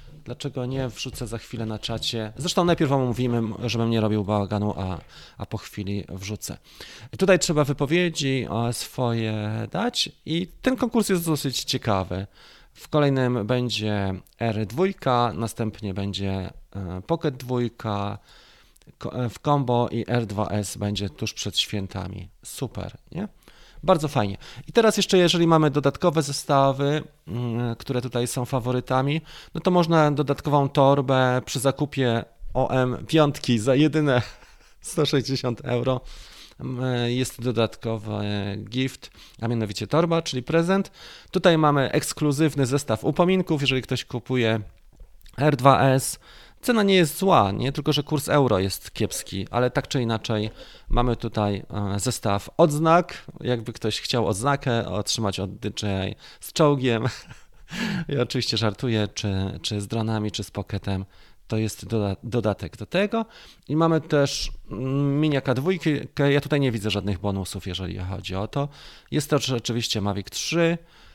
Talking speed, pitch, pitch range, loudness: 130 wpm, 125 Hz, 105-145 Hz, -24 LUFS